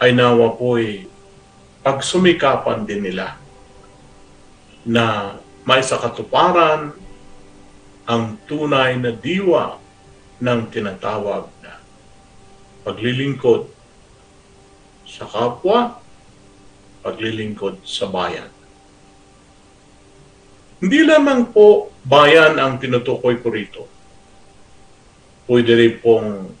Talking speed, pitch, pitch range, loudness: 70 wpm, 115 Hz, 100-135 Hz, -16 LUFS